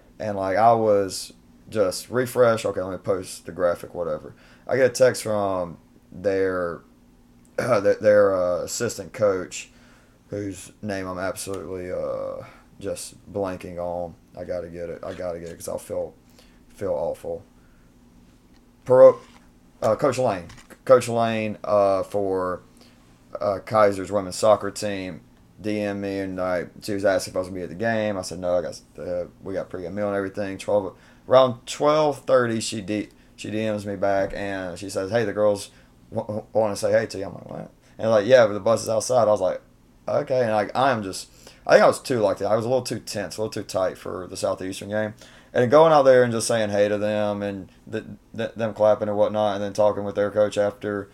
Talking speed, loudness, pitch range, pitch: 200 wpm, -23 LUFS, 95-115 Hz, 105 Hz